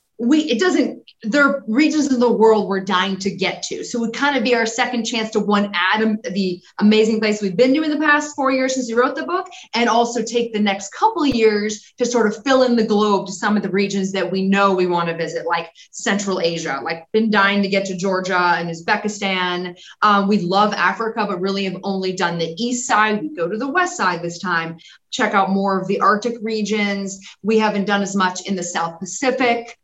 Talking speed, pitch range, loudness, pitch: 235 wpm, 190-235 Hz, -18 LUFS, 210 Hz